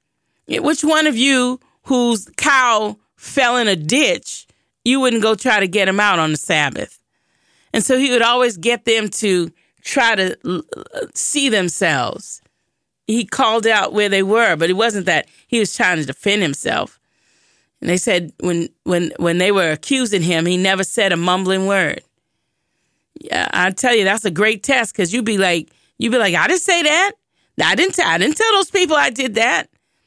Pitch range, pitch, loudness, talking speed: 190-255 Hz, 220 Hz, -16 LUFS, 190 wpm